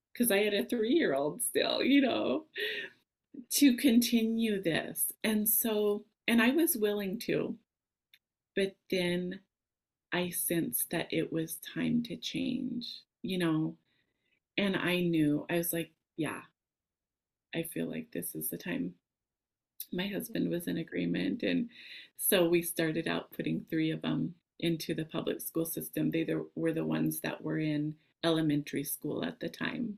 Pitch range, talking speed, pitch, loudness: 160-230 Hz, 155 wpm, 180 Hz, -32 LUFS